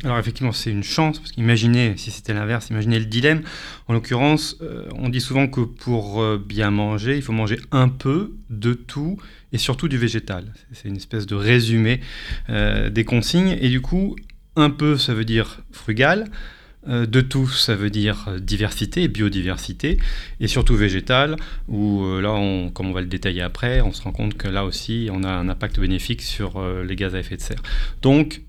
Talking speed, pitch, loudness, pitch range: 200 wpm, 115 Hz, -21 LUFS, 105-130 Hz